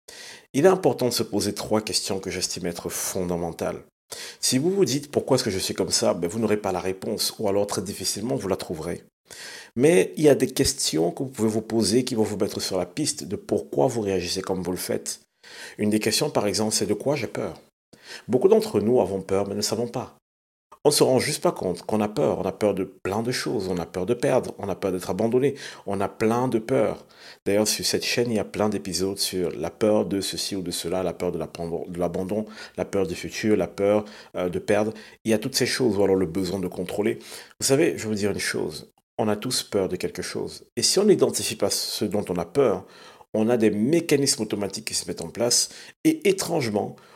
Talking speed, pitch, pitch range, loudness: 245 wpm, 105 Hz, 95-120 Hz, -24 LUFS